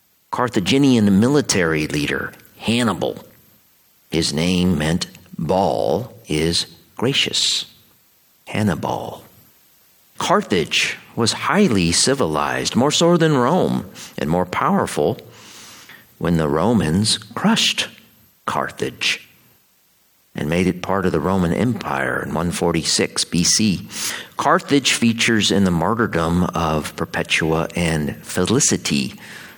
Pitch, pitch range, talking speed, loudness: 90 Hz, 80-110 Hz, 100 wpm, -19 LUFS